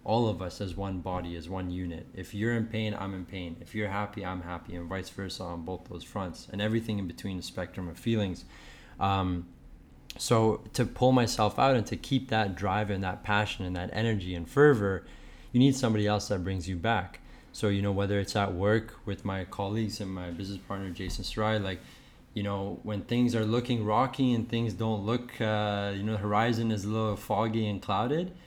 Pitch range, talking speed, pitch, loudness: 95-110 Hz, 215 wpm, 100 Hz, -30 LUFS